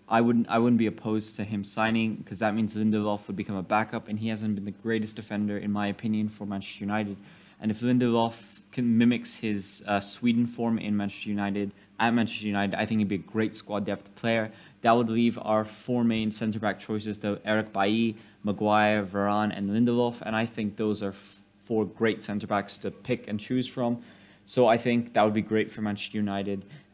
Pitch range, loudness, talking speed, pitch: 100-115 Hz, -28 LUFS, 210 wpm, 105 Hz